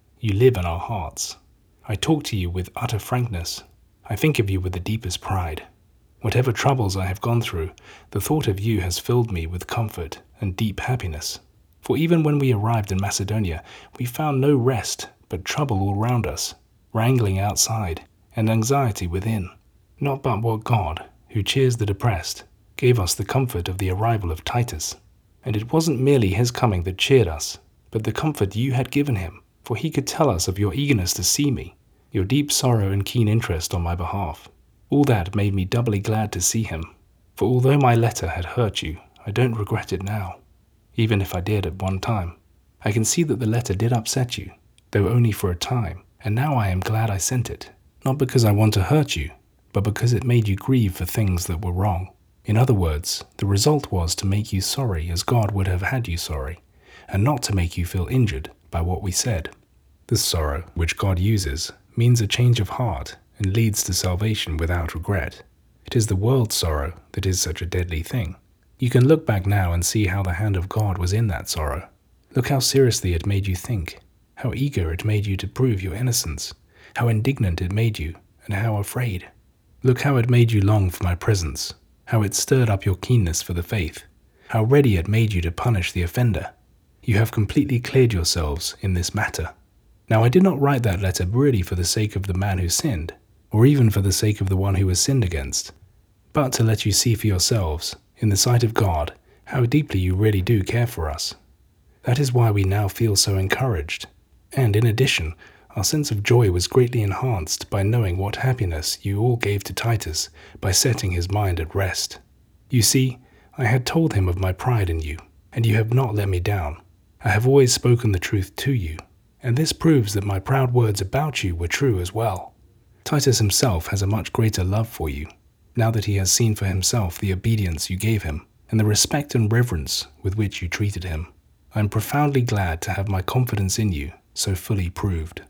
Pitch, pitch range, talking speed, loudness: 105 Hz, 90-120 Hz, 210 wpm, -22 LUFS